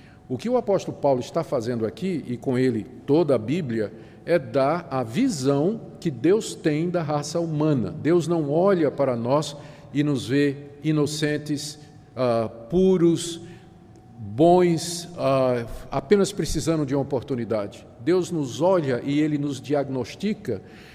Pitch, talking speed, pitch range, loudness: 145 Hz, 140 wpm, 130-170 Hz, -24 LUFS